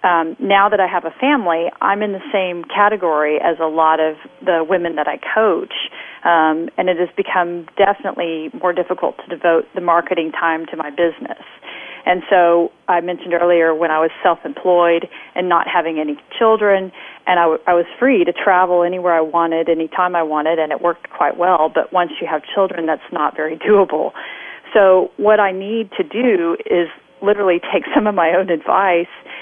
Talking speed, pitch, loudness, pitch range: 190 wpm, 175 Hz, -16 LUFS, 165-190 Hz